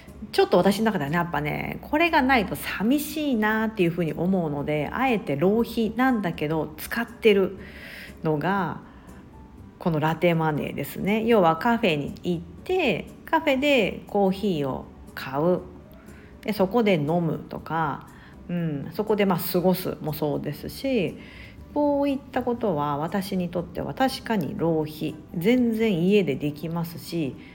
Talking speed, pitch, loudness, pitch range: 290 characters per minute, 190 Hz, -25 LUFS, 165-230 Hz